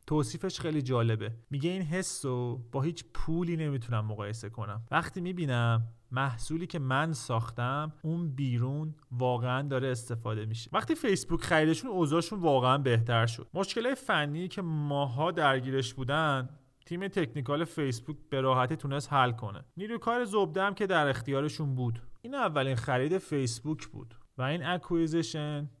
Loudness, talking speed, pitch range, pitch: -31 LUFS, 145 wpm, 125-165 Hz, 145 Hz